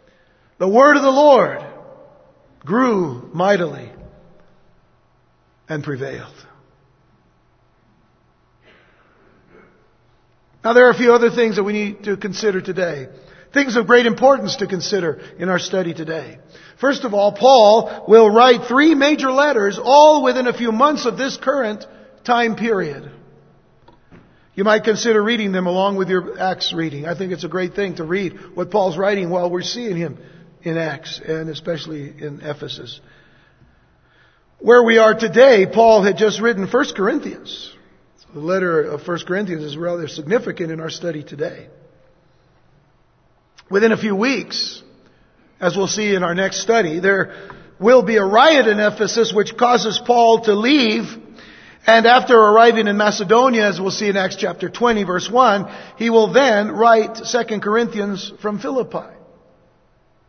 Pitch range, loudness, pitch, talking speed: 175-235 Hz, -16 LUFS, 205 Hz, 150 wpm